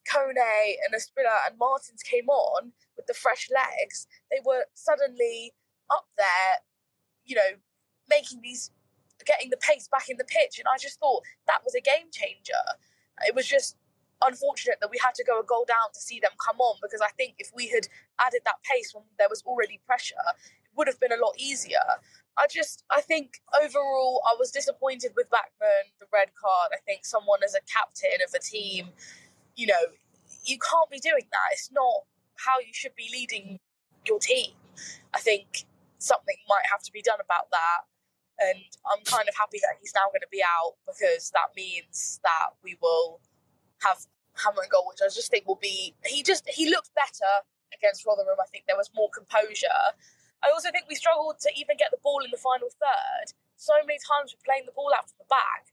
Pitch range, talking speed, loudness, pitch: 230-315 Hz, 200 wpm, -27 LUFS, 280 Hz